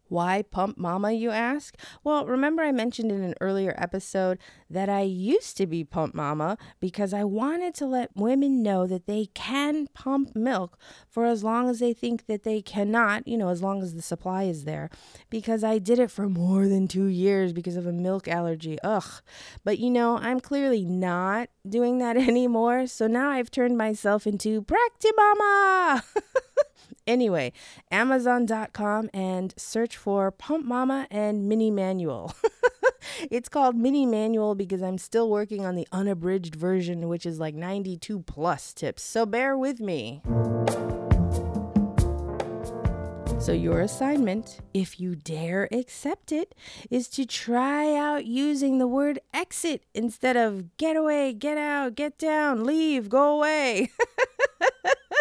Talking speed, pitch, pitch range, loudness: 155 wpm, 220 Hz, 185-265 Hz, -26 LUFS